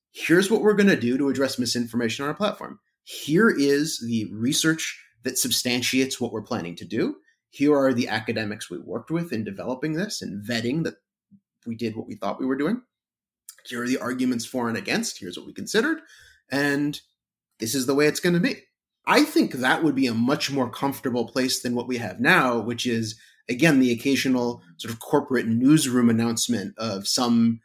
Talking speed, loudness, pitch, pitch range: 195 wpm, -23 LUFS, 125 Hz, 115-145 Hz